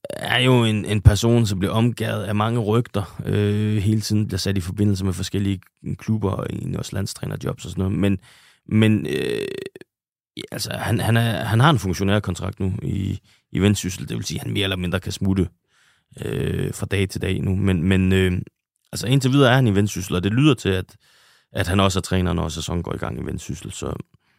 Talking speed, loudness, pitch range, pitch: 215 wpm, -21 LUFS, 95-115 Hz, 105 Hz